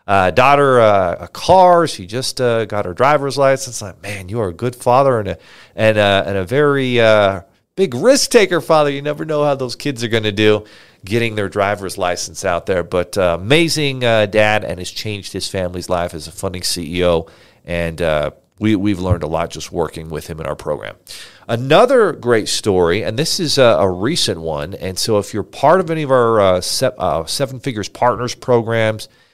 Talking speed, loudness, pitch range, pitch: 210 wpm, -16 LUFS, 90-130 Hz, 105 Hz